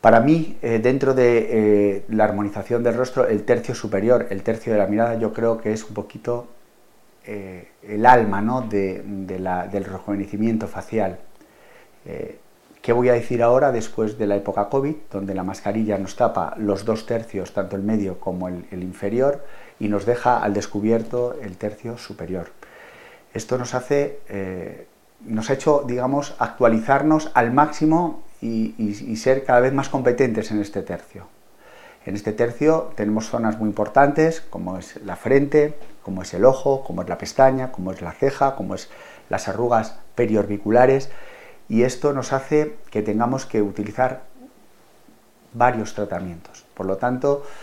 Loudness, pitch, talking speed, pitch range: -21 LUFS, 115 Hz, 165 wpm, 100-130 Hz